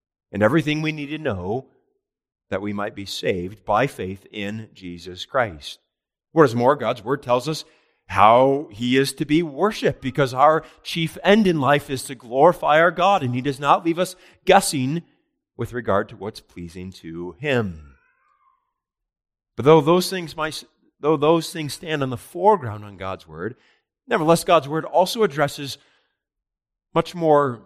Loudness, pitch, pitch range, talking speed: -20 LUFS, 145 Hz, 105-165 Hz, 165 wpm